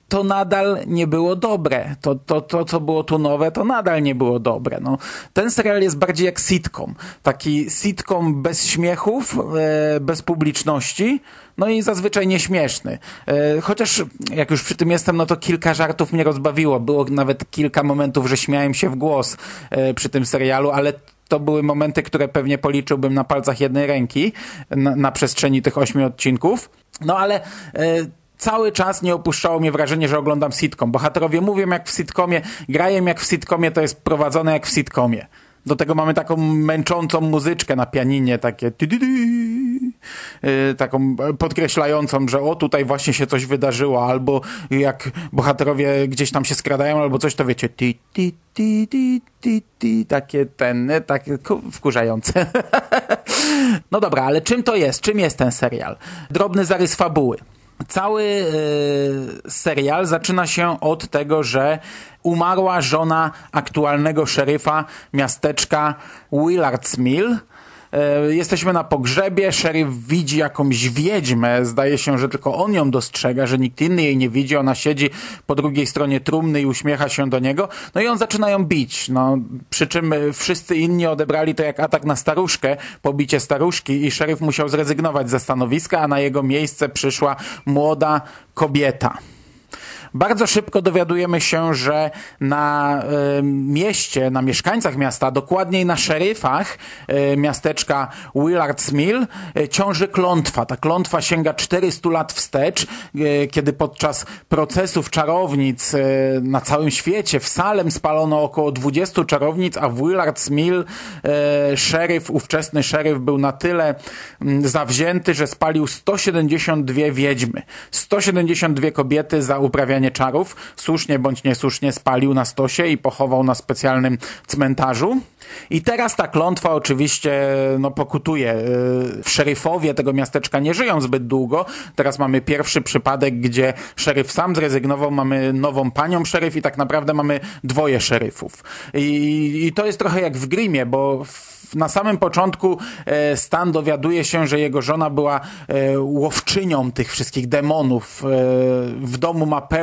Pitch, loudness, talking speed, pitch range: 150 Hz, -18 LUFS, 150 wpm, 140-170 Hz